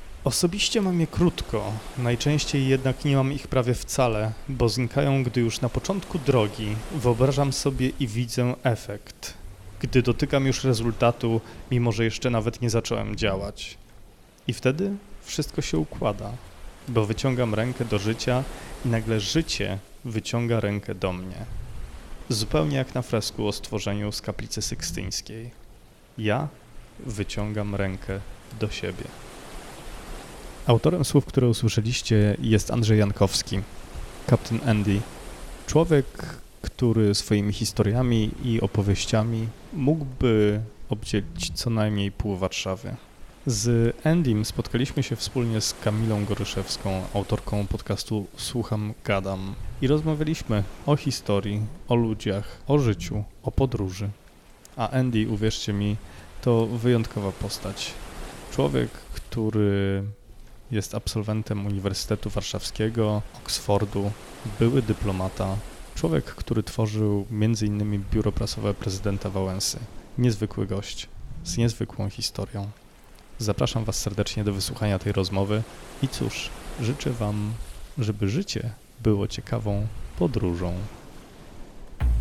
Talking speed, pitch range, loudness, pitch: 110 wpm, 100-125 Hz, -26 LUFS, 110 Hz